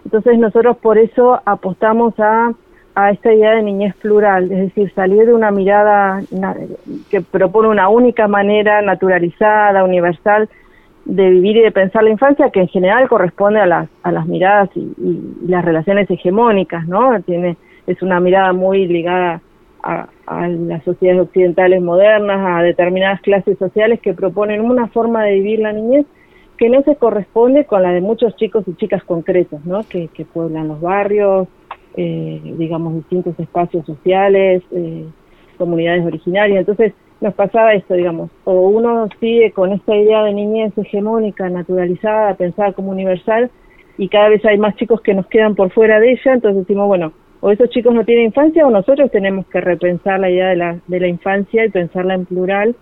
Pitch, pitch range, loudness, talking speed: 195 Hz, 180-220 Hz, -13 LUFS, 175 wpm